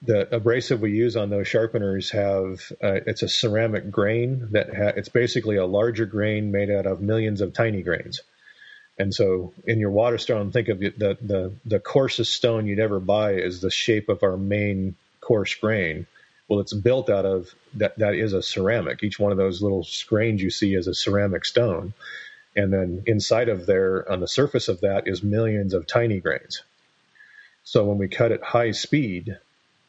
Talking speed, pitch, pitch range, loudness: 190 wpm, 105 Hz, 95-115 Hz, -23 LUFS